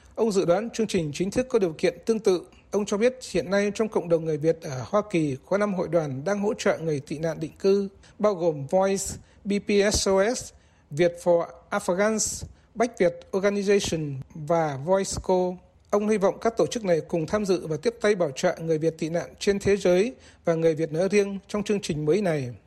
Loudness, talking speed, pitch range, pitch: -25 LUFS, 215 wpm, 165-205 Hz, 185 Hz